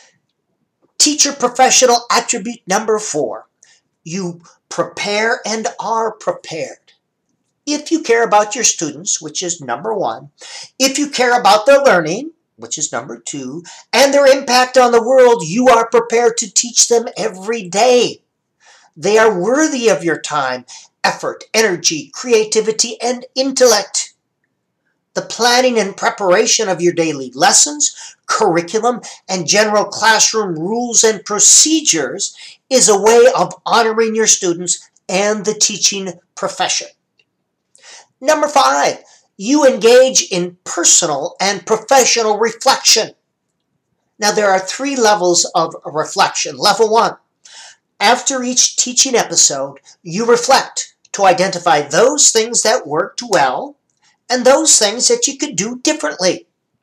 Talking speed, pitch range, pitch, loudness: 125 wpm, 190-255 Hz, 225 Hz, -13 LUFS